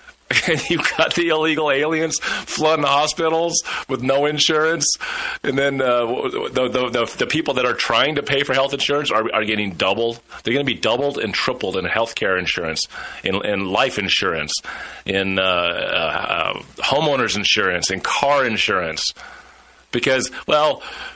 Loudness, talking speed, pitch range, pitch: -19 LUFS, 160 wpm, 115-160 Hz, 140 Hz